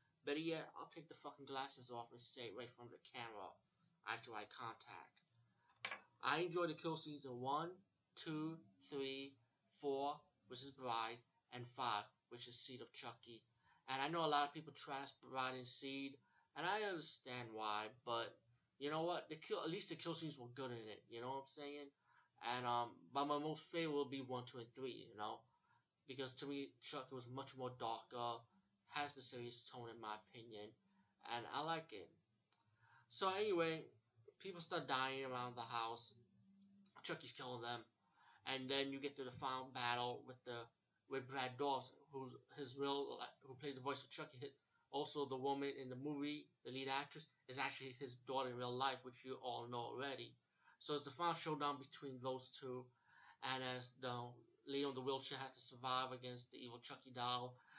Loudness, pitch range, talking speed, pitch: -46 LUFS, 120-145 Hz, 190 wpm, 130 Hz